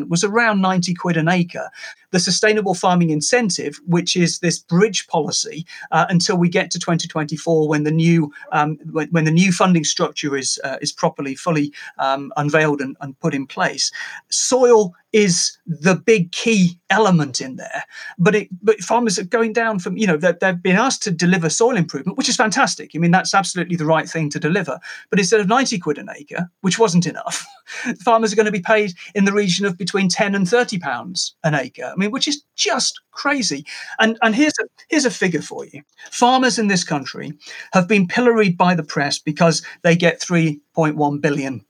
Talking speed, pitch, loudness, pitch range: 195 wpm, 180 Hz, -18 LUFS, 160-215 Hz